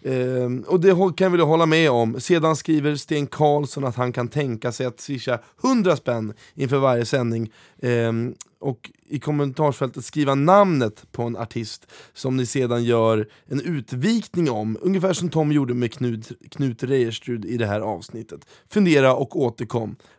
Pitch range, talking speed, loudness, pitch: 120-150 Hz, 165 wpm, -22 LUFS, 130 Hz